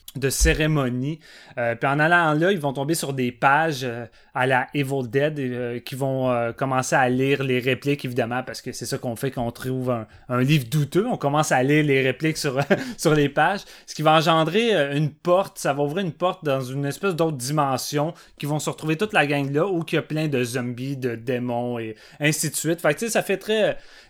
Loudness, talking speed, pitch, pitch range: -23 LUFS, 235 wpm, 140 Hz, 130-160 Hz